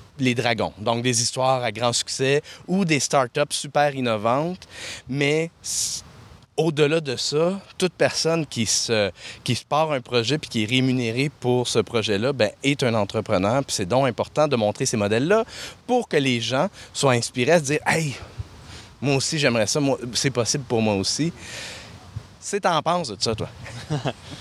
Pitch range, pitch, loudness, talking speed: 115-150 Hz, 130 Hz, -22 LUFS, 170 wpm